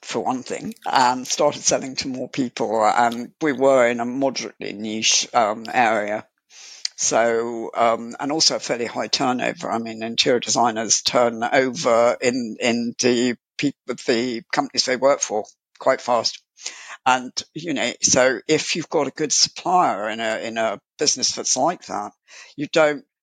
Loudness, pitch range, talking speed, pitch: -20 LUFS, 115-145 Hz, 165 wpm, 125 Hz